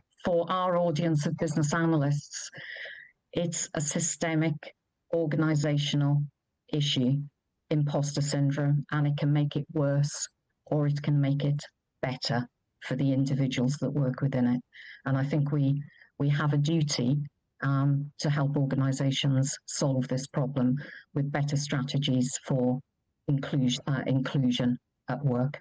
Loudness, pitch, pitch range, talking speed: -29 LUFS, 145 Hz, 135-150 Hz, 130 wpm